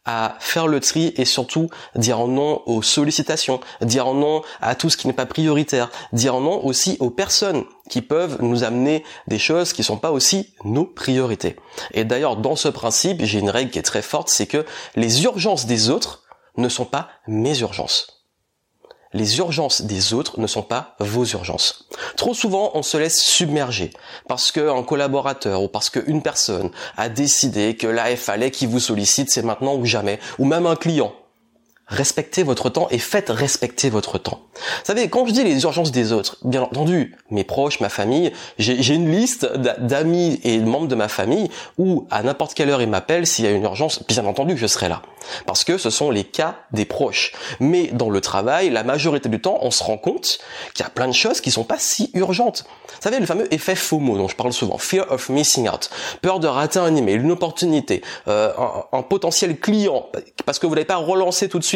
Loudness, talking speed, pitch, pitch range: -19 LUFS, 210 wpm, 135 Hz, 115-165 Hz